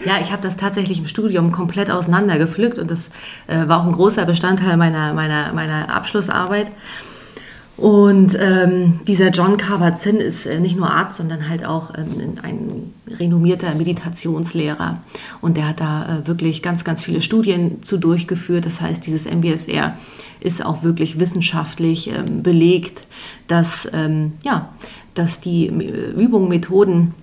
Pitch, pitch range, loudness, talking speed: 175 Hz, 165-190 Hz, -17 LUFS, 150 wpm